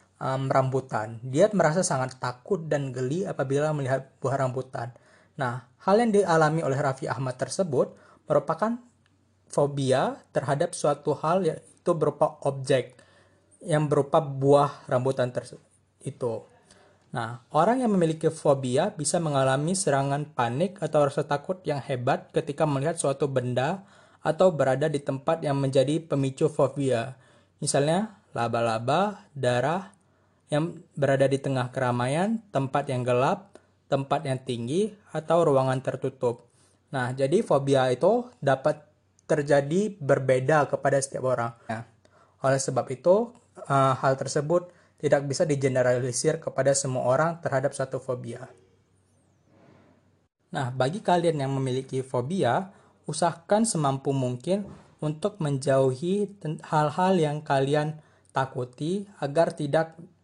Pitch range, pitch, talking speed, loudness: 130-160 Hz, 140 Hz, 120 wpm, -26 LUFS